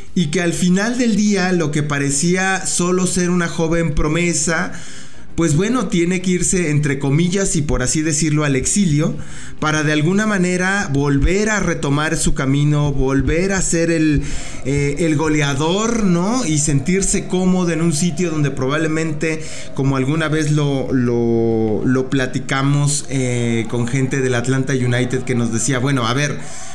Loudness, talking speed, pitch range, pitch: -17 LUFS, 160 wpm, 135-175 Hz, 155 Hz